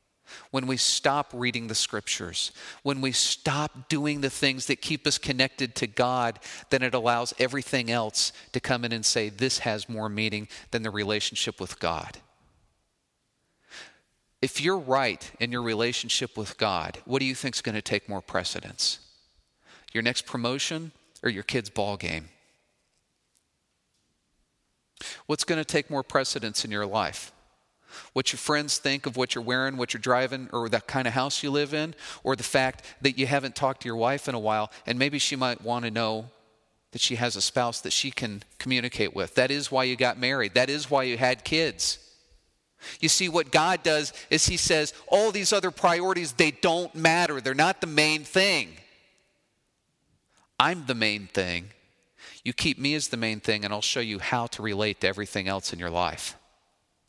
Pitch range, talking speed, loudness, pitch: 110-140 Hz, 185 wpm, -26 LUFS, 125 Hz